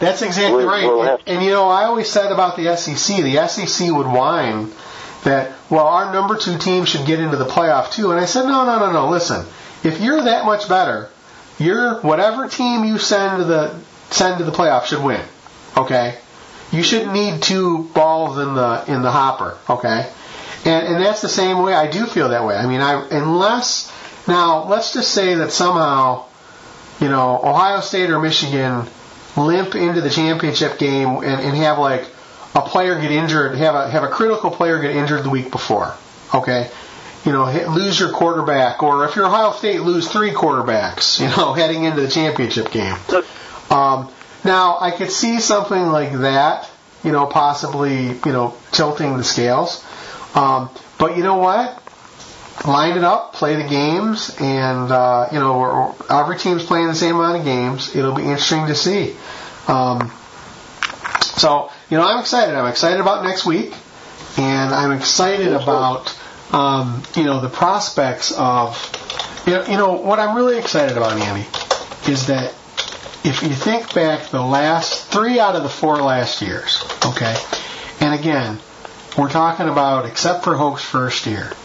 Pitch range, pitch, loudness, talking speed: 135-185 Hz, 155 Hz, -17 LUFS, 180 wpm